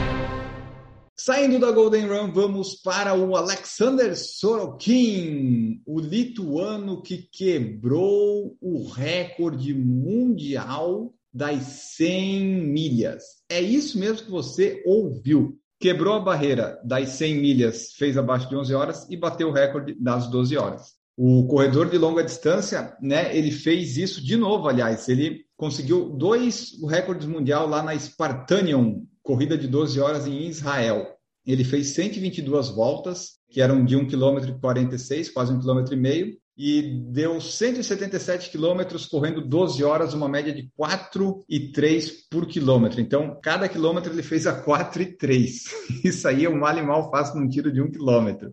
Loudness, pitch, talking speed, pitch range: -23 LUFS, 155 Hz, 150 wpm, 135-185 Hz